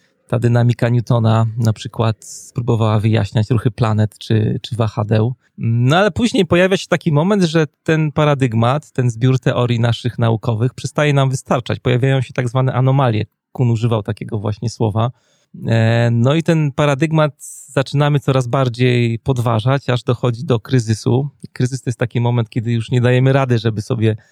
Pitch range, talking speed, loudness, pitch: 115-140 Hz, 160 wpm, -16 LUFS, 125 Hz